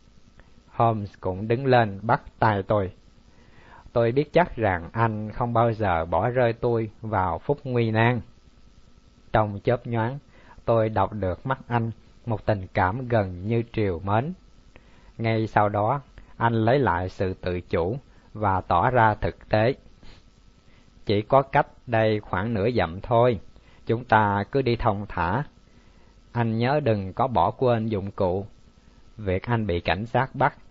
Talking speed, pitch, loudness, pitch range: 155 wpm, 110 Hz, -24 LUFS, 100-120 Hz